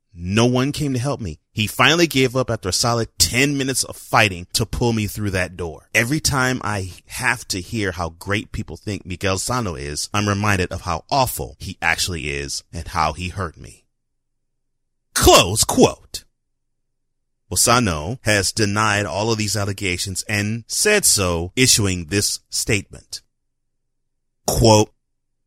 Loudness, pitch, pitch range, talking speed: -19 LUFS, 105 Hz, 90-120 Hz, 155 wpm